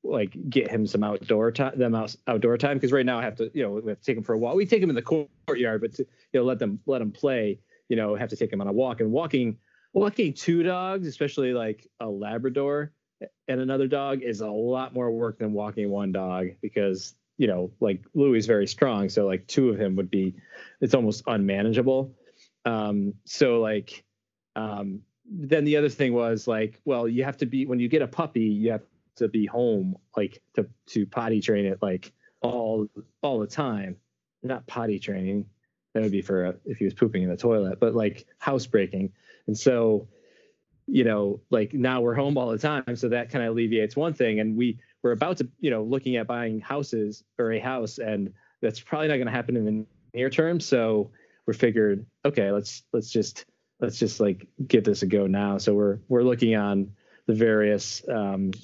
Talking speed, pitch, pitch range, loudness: 215 wpm, 115 Hz, 105-130 Hz, -26 LUFS